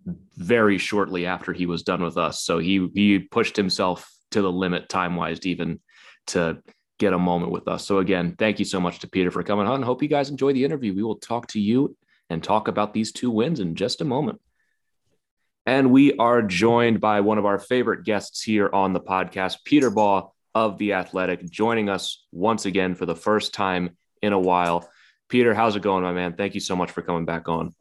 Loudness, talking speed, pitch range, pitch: -23 LUFS, 215 wpm, 90-110 Hz, 100 Hz